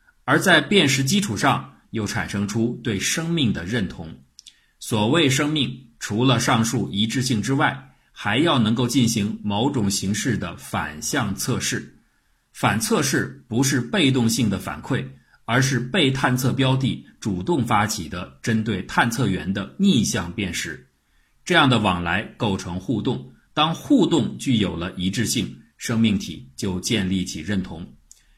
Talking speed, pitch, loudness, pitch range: 220 characters per minute, 110 Hz, -22 LUFS, 95-130 Hz